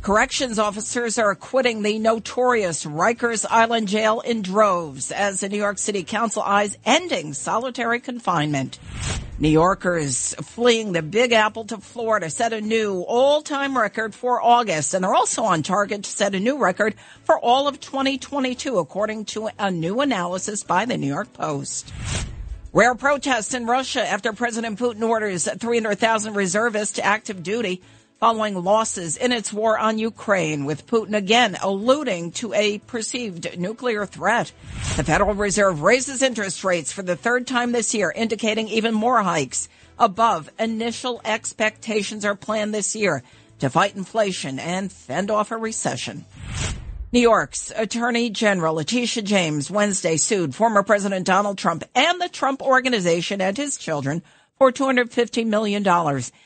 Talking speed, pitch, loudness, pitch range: 150 wpm, 215 Hz, -21 LUFS, 190-235 Hz